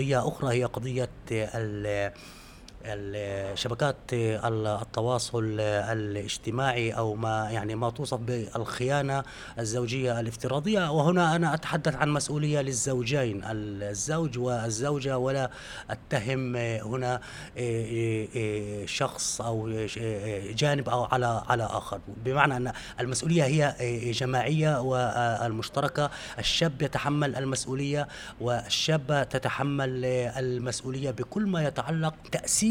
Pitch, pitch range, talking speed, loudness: 125 Hz, 110-140 Hz, 90 wpm, -29 LUFS